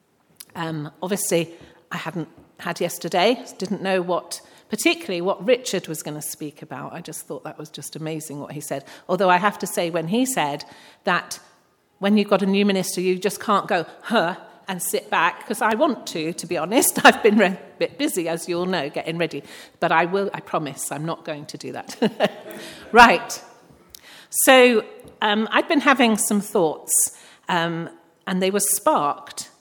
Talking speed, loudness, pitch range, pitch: 190 wpm, -21 LUFS, 165-215 Hz, 180 Hz